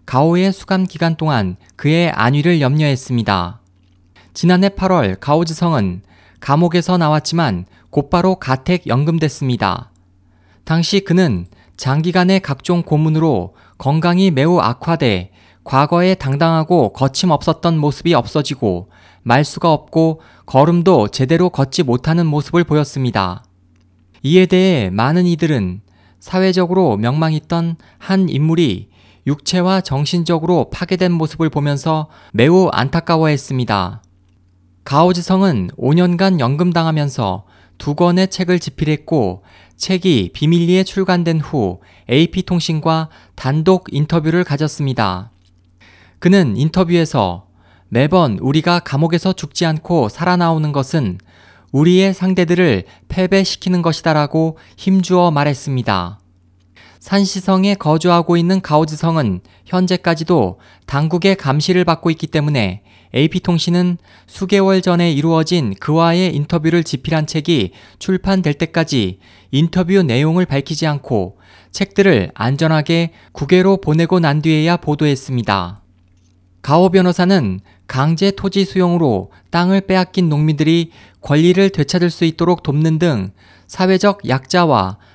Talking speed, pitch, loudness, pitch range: 285 characters per minute, 155 Hz, -15 LUFS, 110-175 Hz